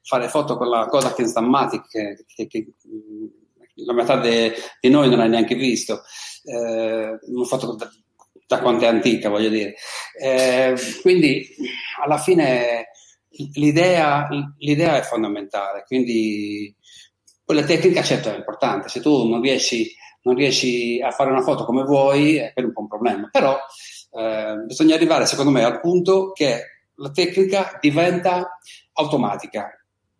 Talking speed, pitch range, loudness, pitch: 145 wpm, 115-175 Hz, -19 LUFS, 135 Hz